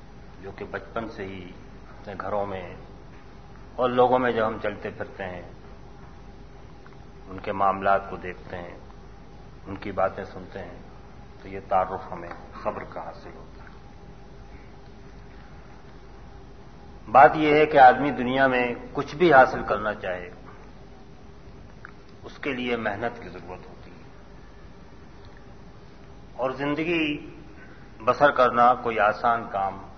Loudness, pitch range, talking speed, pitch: -23 LUFS, 95-125 Hz, 125 wpm, 105 Hz